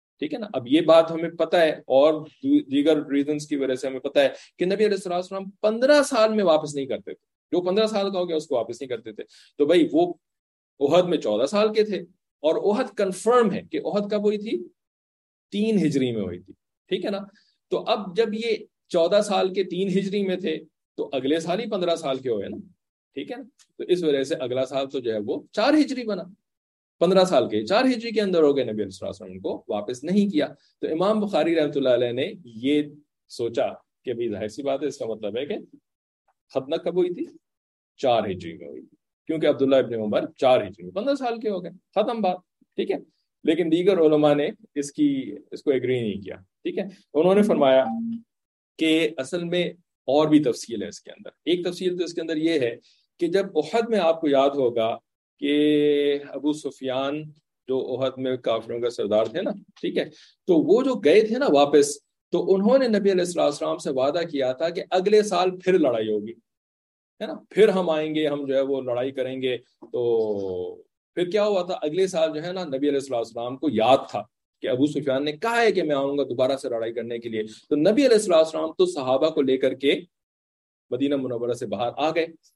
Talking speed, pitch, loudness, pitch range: 220 wpm, 165 Hz, -23 LUFS, 140-210 Hz